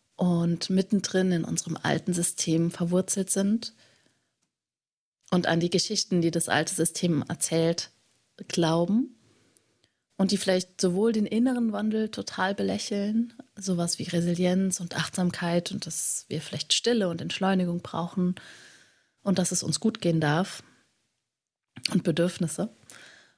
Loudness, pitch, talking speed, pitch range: -27 LUFS, 180 Hz, 125 wpm, 170-200 Hz